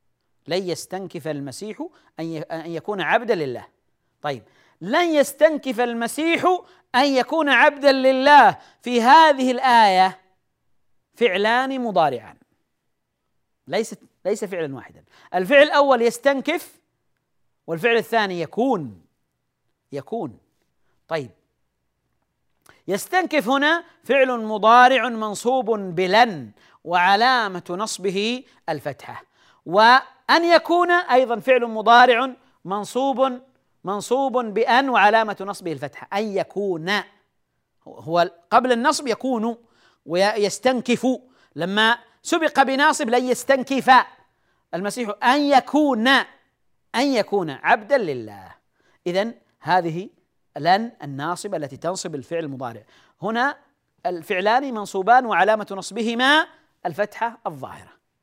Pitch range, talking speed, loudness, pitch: 185-265 Hz, 90 wpm, -19 LUFS, 230 Hz